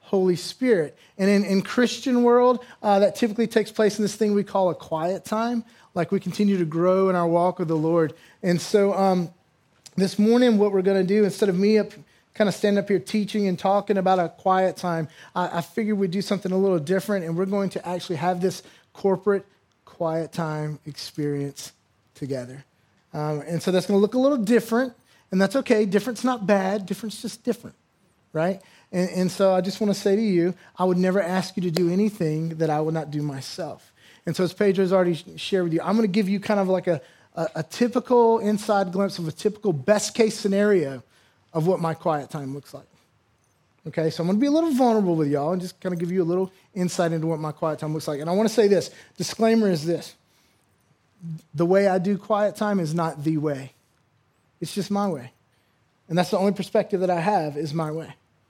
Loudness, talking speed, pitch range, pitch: -23 LUFS, 225 wpm, 160-205 Hz, 185 Hz